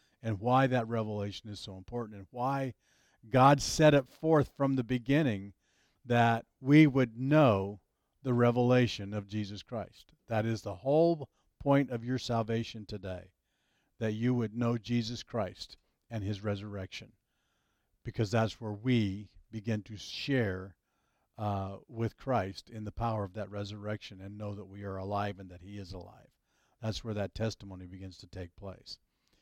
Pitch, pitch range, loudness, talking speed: 110 Hz, 100-120 Hz, -32 LUFS, 160 wpm